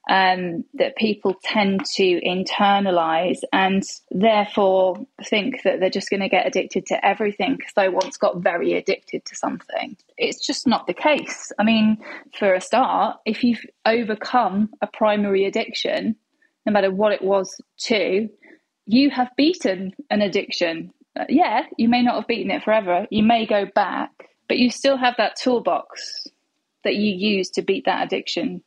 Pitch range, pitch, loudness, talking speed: 195-260 Hz, 215 Hz, -21 LUFS, 165 wpm